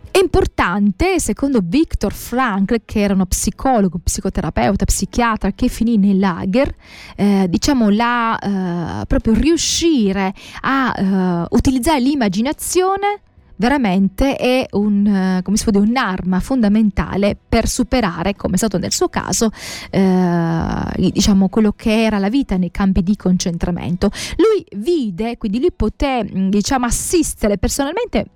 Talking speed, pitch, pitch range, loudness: 125 wpm, 215 Hz, 195-260 Hz, -17 LUFS